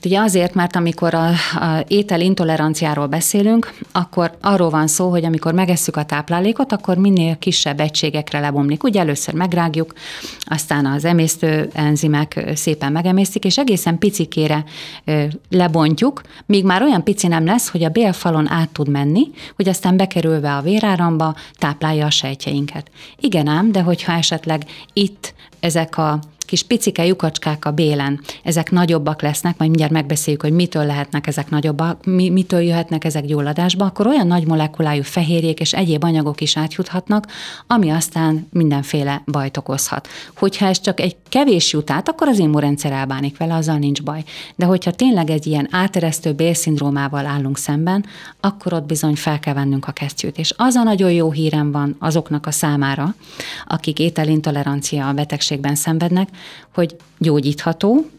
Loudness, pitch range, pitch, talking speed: -17 LUFS, 150-180 Hz, 160 Hz, 155 wpm